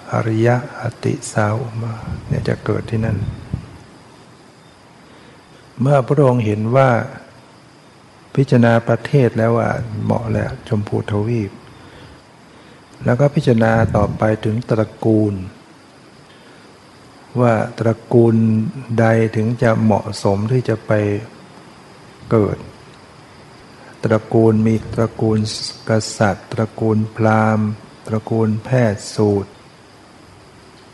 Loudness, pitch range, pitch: -17 LUFS, 110-120 Hz, 110 Hz